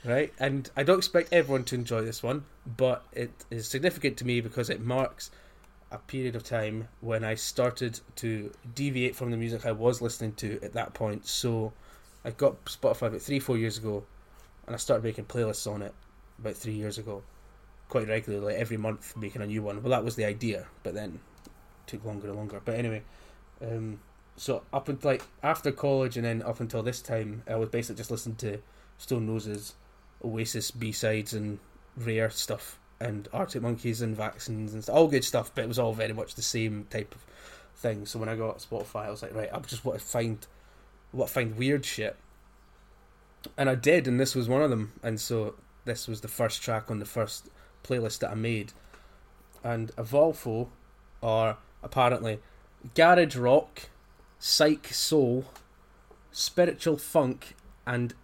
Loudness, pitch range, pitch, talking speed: -30 LUFS, 110-125 Hz, 115 Hz, 185 wpm